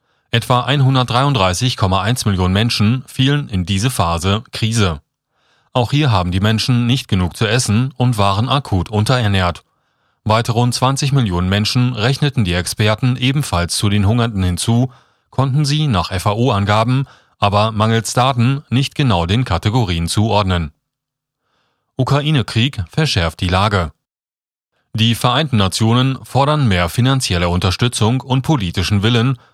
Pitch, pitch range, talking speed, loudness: 115 Hz, 100-130 Hz, 125 wpm, -16 LUFS